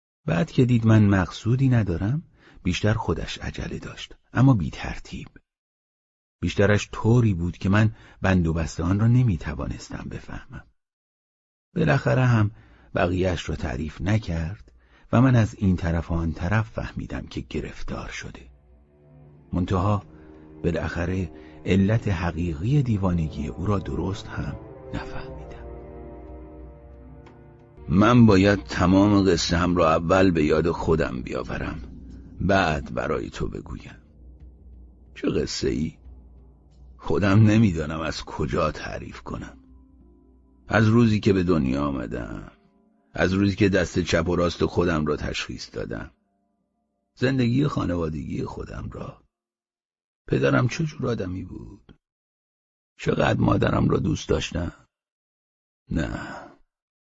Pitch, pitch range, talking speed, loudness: 90 Hz, 75-105 Hz, 110 wpm, -23 LUFS